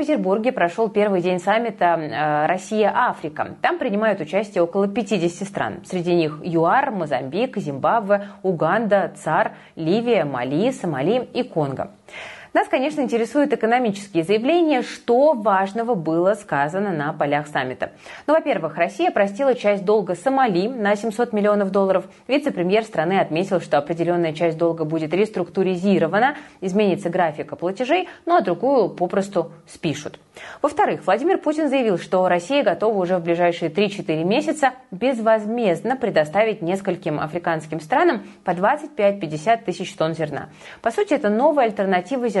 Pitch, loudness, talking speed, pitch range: 200 Hz, -21 LUFS, 130 wpm, 175-235 Hz